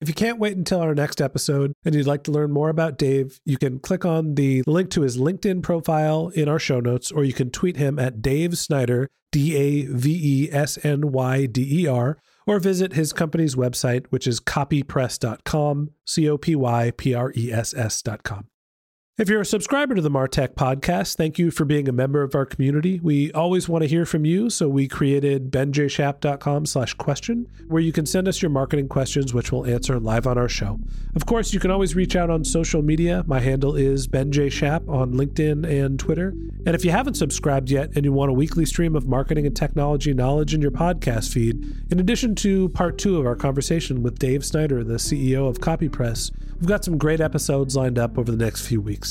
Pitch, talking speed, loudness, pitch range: 145 Hz, 215 wpm, -22 LUFS, 130-165 Hz